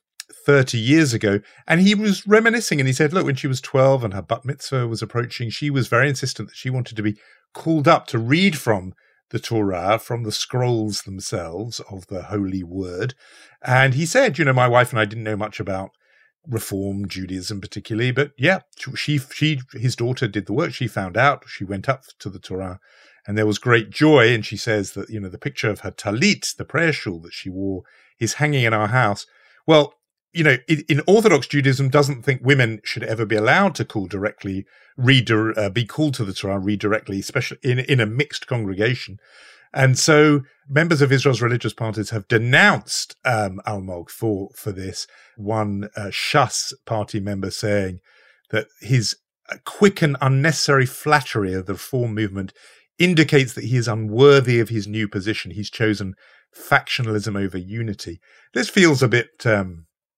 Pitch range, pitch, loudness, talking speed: 105-140 Hz, 115 Hz, -20 LUFS, 180 wpm